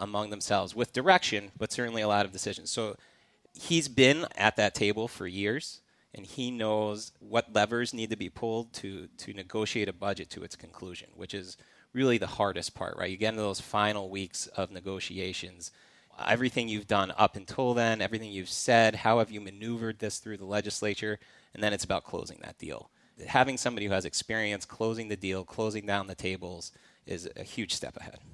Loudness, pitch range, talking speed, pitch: -30 LUFS, 95-115 Hz, 195 wpm, 105 Hz